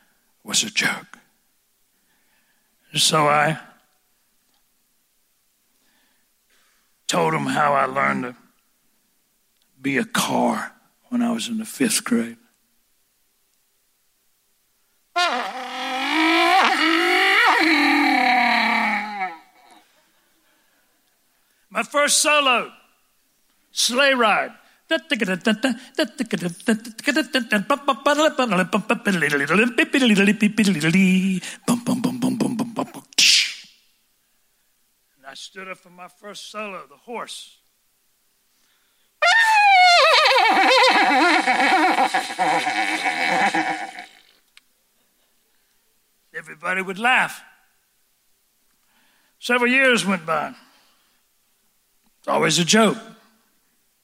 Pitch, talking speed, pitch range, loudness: 245 Hz, 50 wpm, 210-290 Hz, -18 LUFS